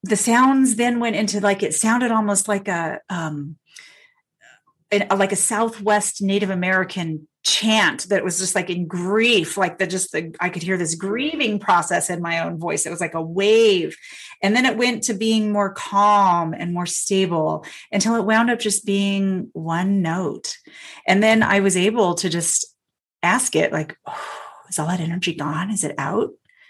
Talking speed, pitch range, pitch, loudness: 185 wpm, 175-220 Hz, 200 Hz, -20 LUFS